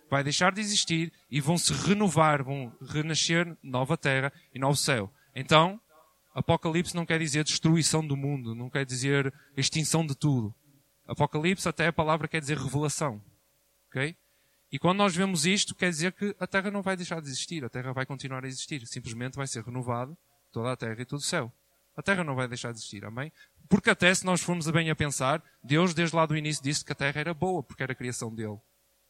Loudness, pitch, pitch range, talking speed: -28 LUFS, 150 Hz, 135-170 Hz, 210 wpm